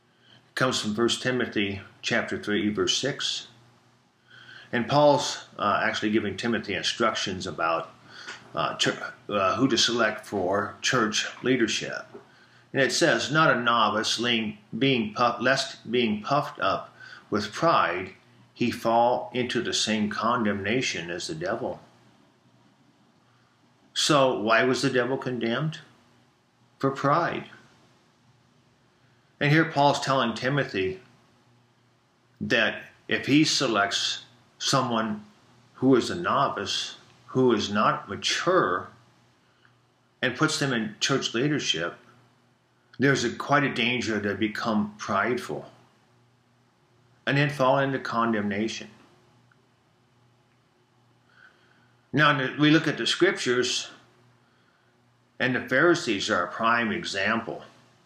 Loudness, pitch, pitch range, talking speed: -25 LUFS, 120 Hz, 115-130 Hz, 110 wpm